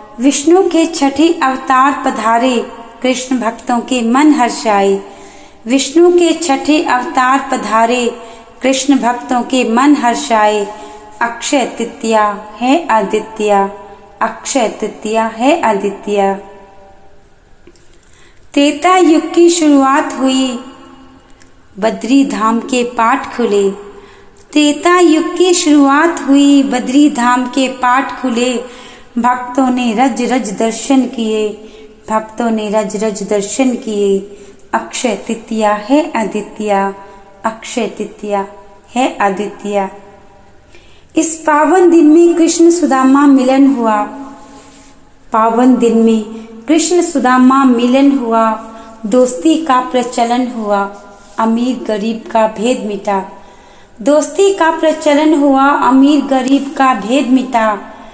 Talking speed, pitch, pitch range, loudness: 105 wpm, 245 Hz, 215-275 Hz, -12 LUFS